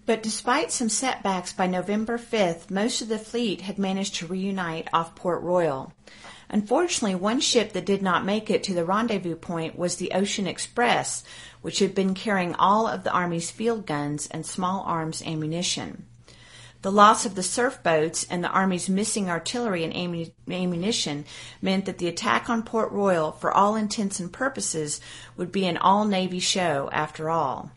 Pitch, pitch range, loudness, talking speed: 190 Hz, 170-215 Hz, -25 LUFS, 175 wpm